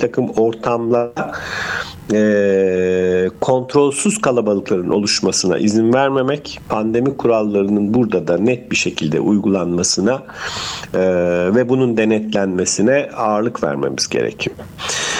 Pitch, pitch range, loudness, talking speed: 105 Hz, 95-125 Hz, -17 LUFS, 95 wpm